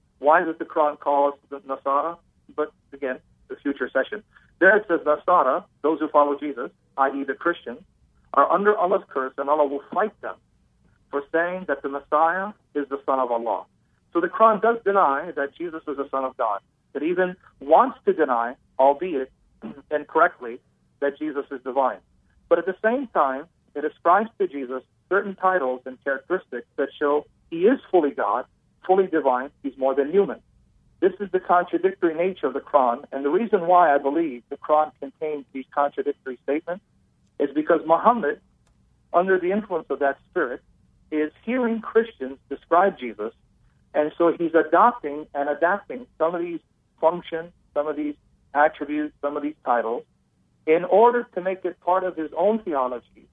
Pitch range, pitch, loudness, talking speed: 140-180 Hz, 150 Hz, -23 LUFS, 170 wpm